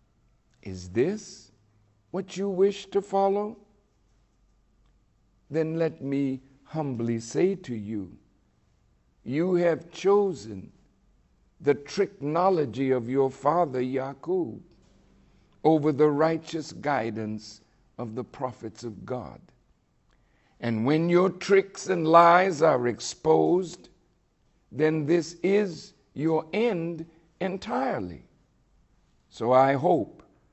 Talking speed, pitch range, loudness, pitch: 95 wpm, 120-180 Hz, -26 LUFS, 155 Hz